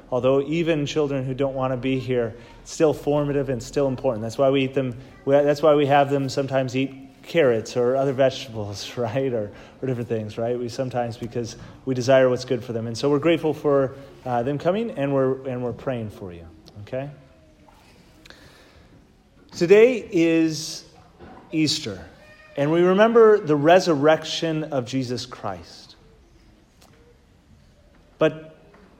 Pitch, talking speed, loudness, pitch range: 135 Hz, 155 wpm, -22 LUFS, 120-150 Hz